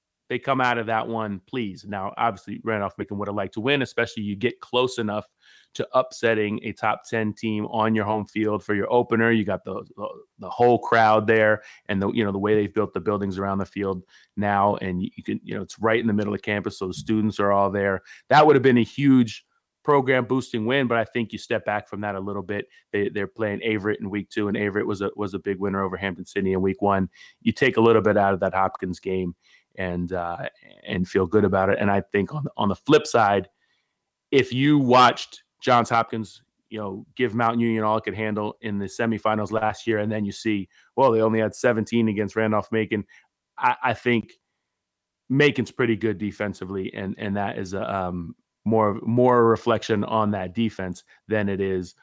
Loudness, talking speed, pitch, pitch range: -23 LUFS, 225 wpm, 105 Hz, 100-115 Hz